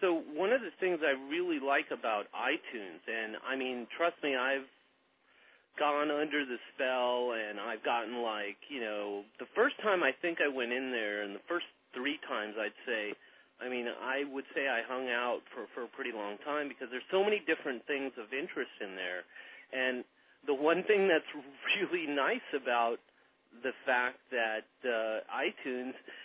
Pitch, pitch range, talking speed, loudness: 130 Hz, 120-150 Hz, 180 wpm, -34 LUFS